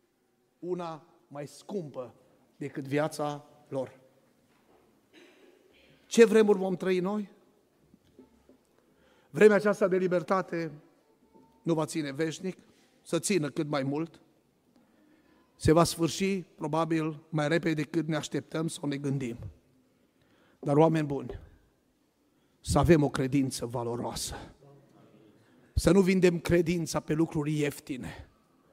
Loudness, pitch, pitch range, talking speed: -29 LUFS, 160 Hz, 140-175 Hz, 105 wpm